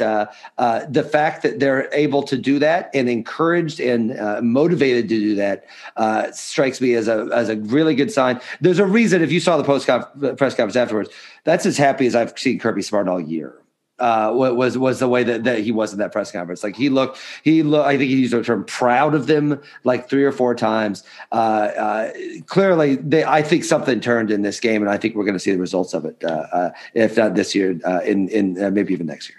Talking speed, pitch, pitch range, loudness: 240 wpm, 125 Hz, 105-145 Hz, -19 LUFS